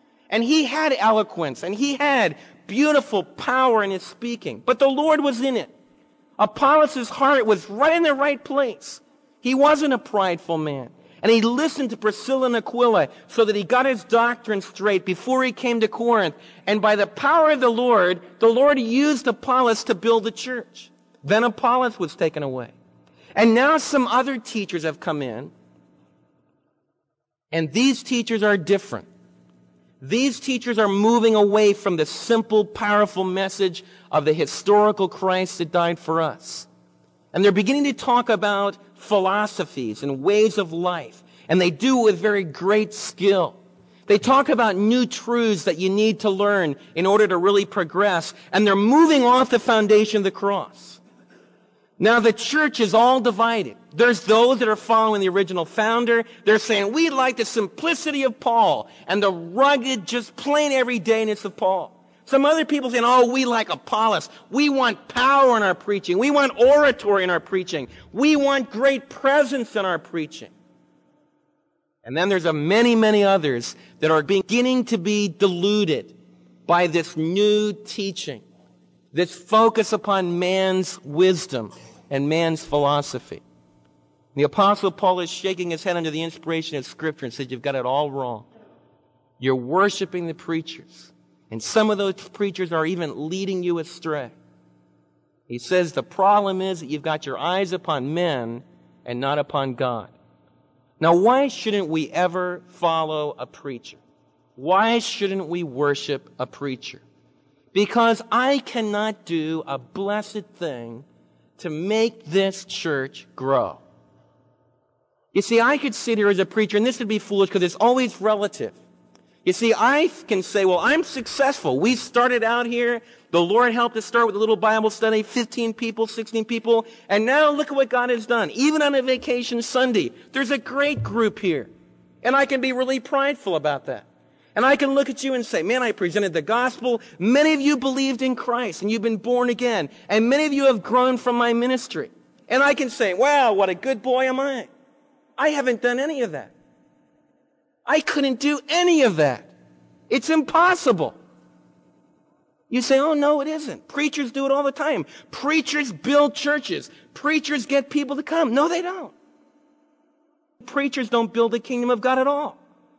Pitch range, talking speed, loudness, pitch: 170-255 Hz, 170 wpm, -21 LUFS, 215 Hz